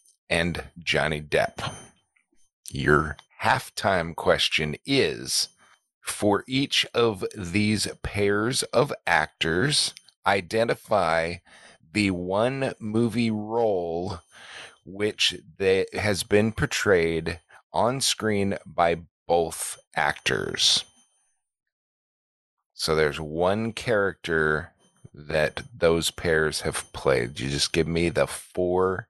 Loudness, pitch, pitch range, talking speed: -25 LUFS, 90 Hz, 80-105 Hz, 90 wpm